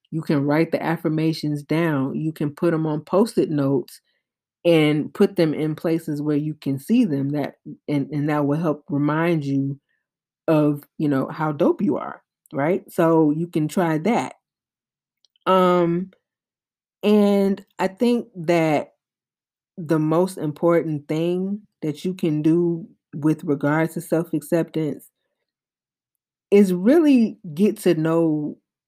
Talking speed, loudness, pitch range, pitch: 140 wpm, -21 LUFS, 150-175 Hz, 160 Hz